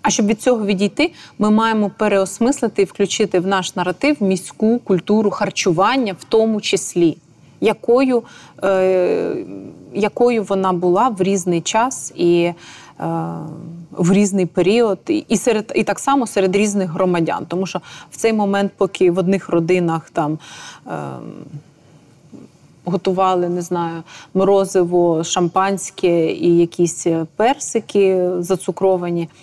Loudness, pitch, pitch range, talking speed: -17 LUFS, 190 Hz, 170-210 Hz, 125 wpm